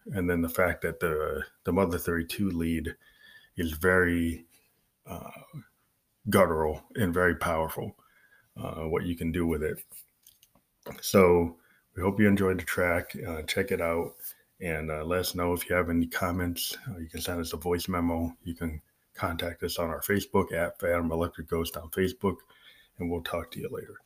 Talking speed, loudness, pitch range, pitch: 180 wpm, -29 LUFS, 85-90 Hz, 85 Hz